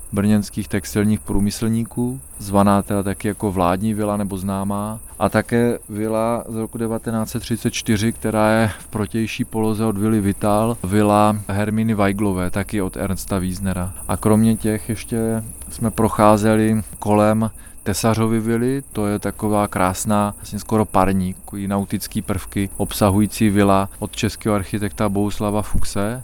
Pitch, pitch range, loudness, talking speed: 105 Hz, 100-110 Hz, -20 LUFS, 135 wpm